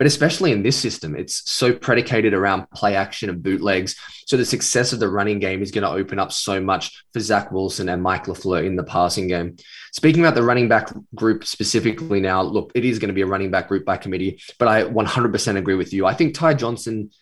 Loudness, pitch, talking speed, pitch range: -20 LUFS, 100 Hz, 235 wpm, 95-115 Hz